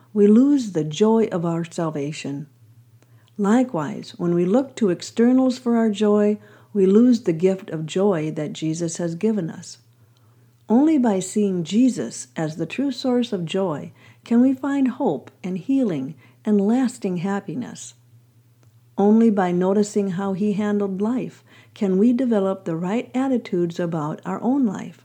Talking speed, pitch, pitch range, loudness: 150 wpm, 195 Hz, 160-225 Hz, -21 LUFS